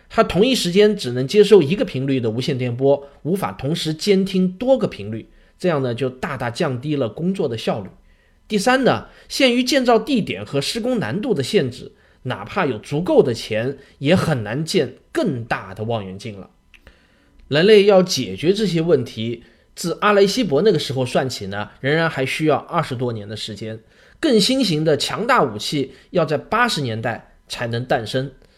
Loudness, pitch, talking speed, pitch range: -19 LUFS, 150 Hz, 270 characters per minute, 125-200 Hz